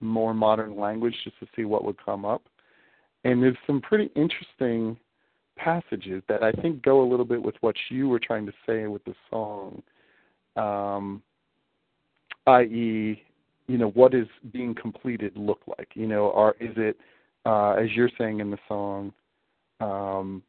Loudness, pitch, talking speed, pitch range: -26 LUFS, 110 Hz, 165 wpm, 105-125 Hz